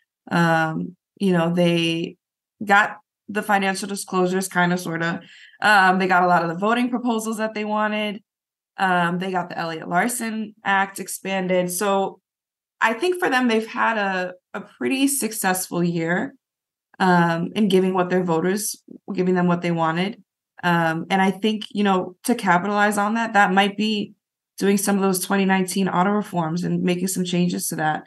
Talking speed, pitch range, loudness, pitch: 175 wpm, 175-210 Hz, -21 LUFS, 190 Hz